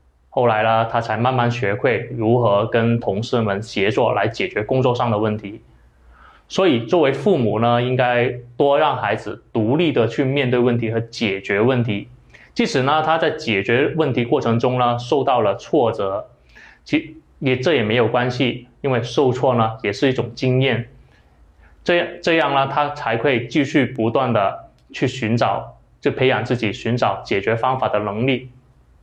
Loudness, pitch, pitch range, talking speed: -19 LUFS, 120 Hz, 110-130 Hz, 245 characters per minute